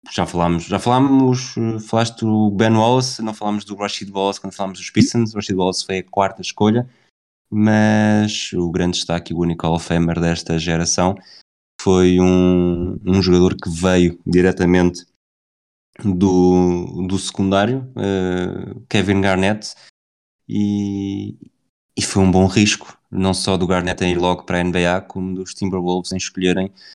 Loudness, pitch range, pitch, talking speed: -18 LUFS, 90-105 Hz, 95 Hz, 150 wpm